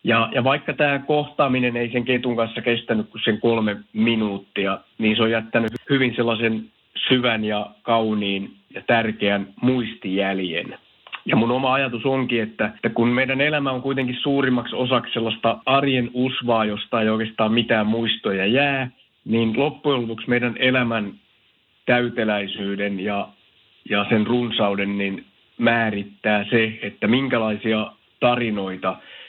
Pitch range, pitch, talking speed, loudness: 110-125 Hz, 115 Hz, 135 wpm, -21 LUFS